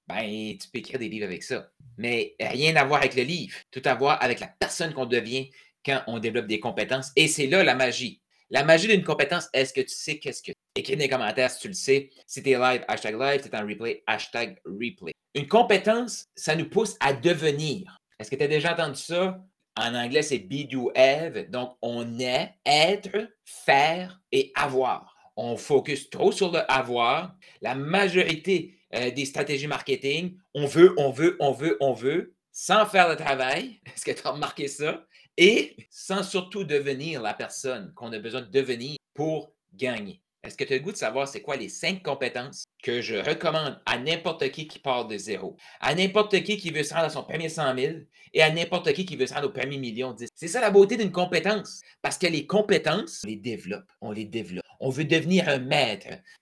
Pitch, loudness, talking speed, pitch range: 150 Hz, -25 LUFS, 210 wpm, 130-185 Hz